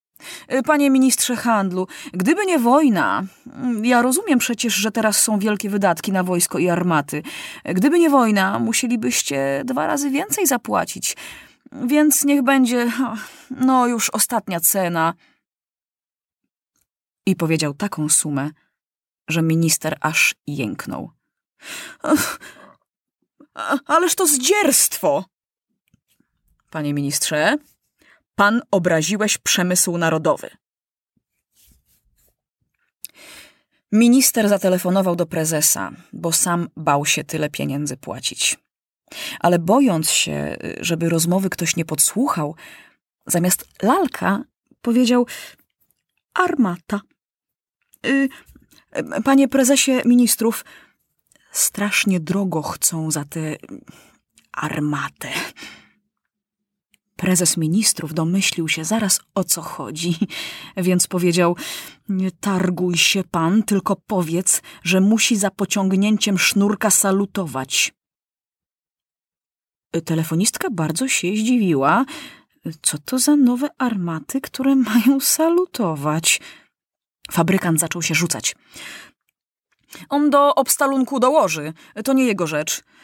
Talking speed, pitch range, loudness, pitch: 95 wpm, 165-250 Hz, -18 LUFS, 195 Hz